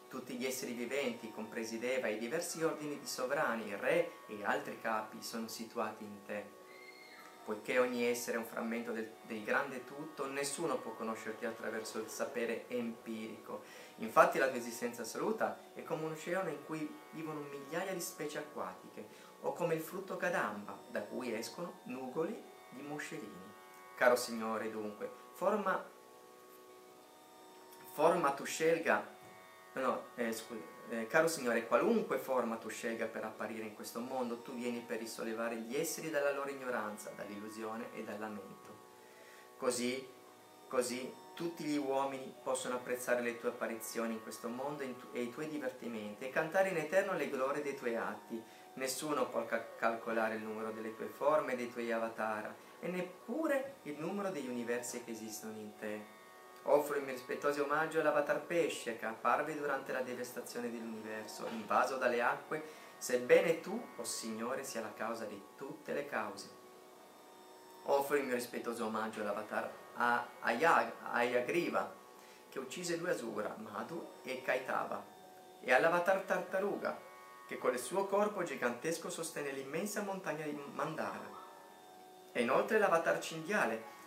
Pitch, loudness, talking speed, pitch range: 120 Hz, -38 LUFS, 150 wpm, 110-145 Hz